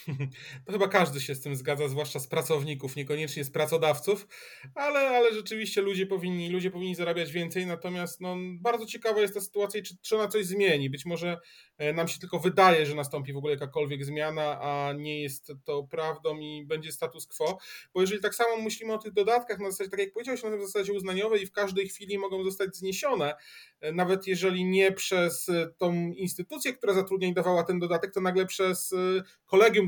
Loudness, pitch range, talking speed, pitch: -29 LUFS, 155-200 Hz, 190 wpm, 180 Hz